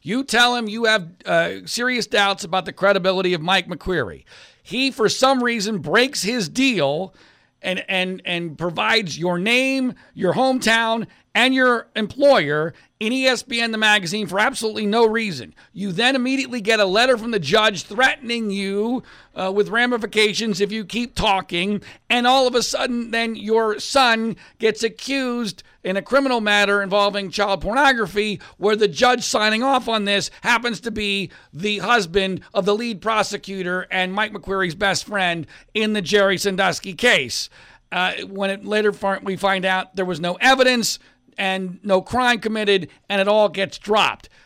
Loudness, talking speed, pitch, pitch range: -19 LUFS, 165 wpm, 210 Hz, 195-235 Hz